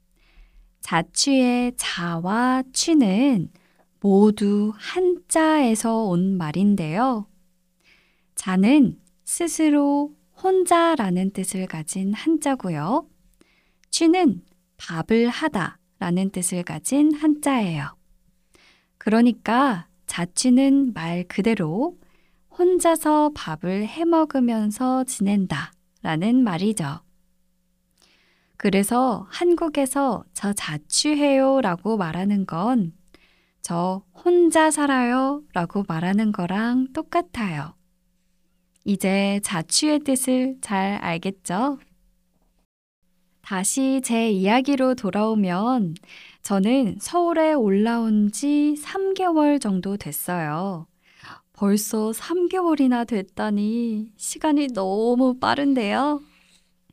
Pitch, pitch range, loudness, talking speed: 210 Hz, 180-270 Hz, -22 LUFS, 180 characters per minute